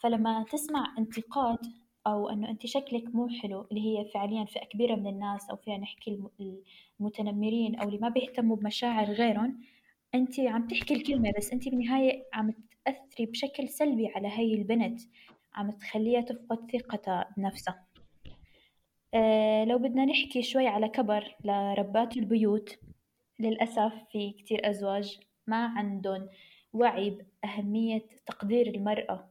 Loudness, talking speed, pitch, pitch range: -31 LUFS, 130 wpm, 220 Hz, 210-240 Hz